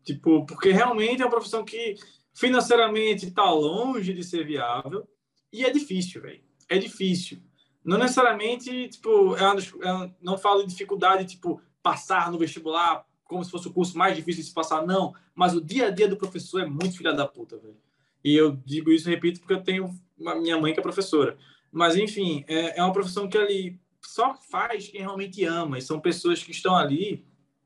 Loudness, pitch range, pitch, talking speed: -25 LUFS, 165-205 Hz, 185 Hz, 195 wpm